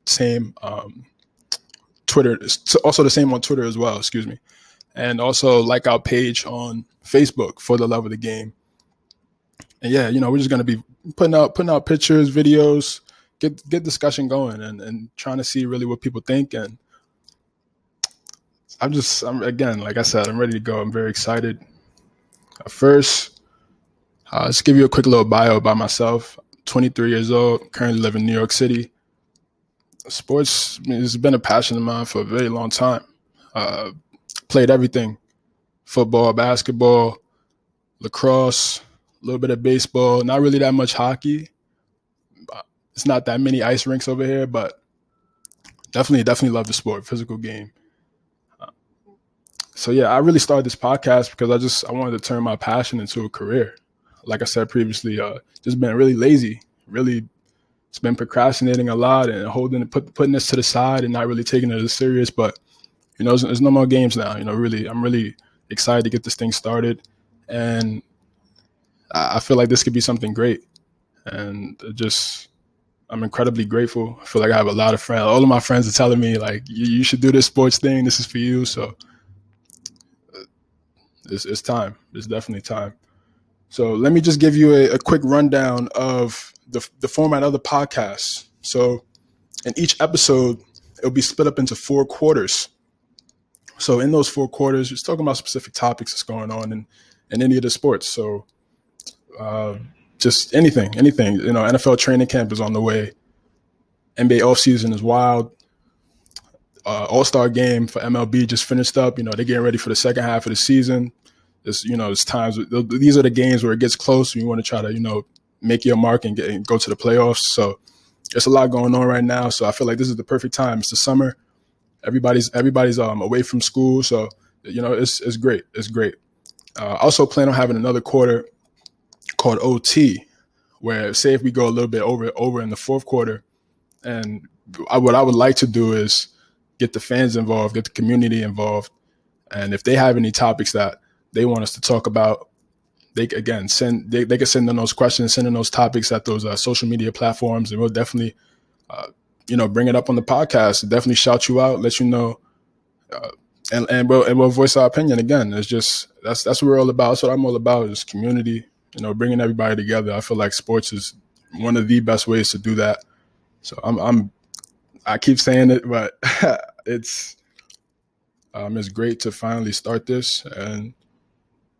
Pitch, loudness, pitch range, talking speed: 120 Hz, -18 LUFS, 115-130 Hz, 195 wpm